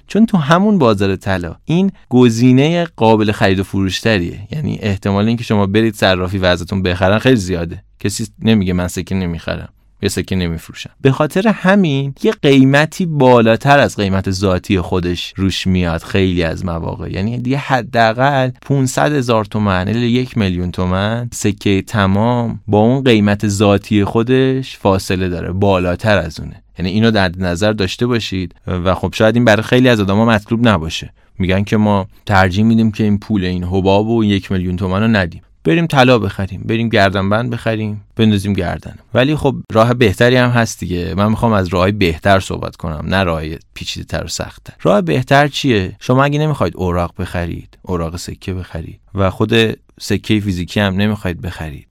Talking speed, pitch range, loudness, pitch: 170 wpm, 95-120 Hz, -15 LUFS, 105 Hz